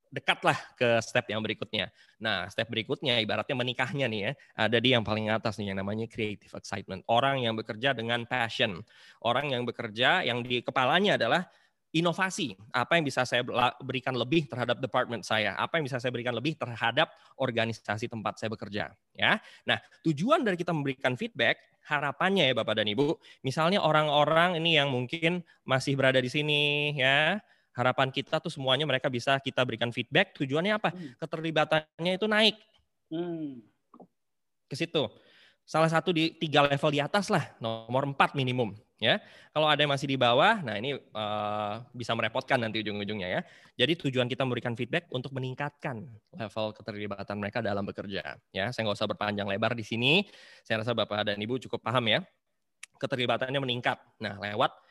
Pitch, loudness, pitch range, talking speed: 130 Hz, -29 LUFS, 115-150 Hz, 165 wpm